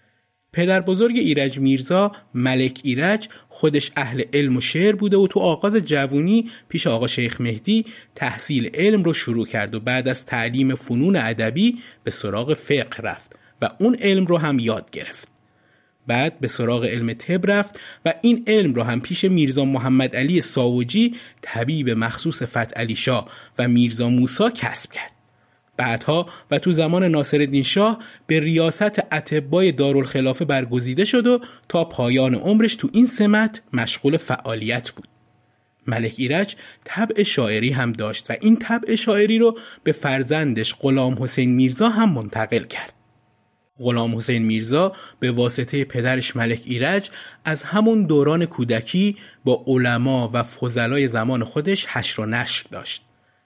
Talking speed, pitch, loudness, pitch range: 150 wpm, 135 Hz, -20 LUFS, 120-185 Hz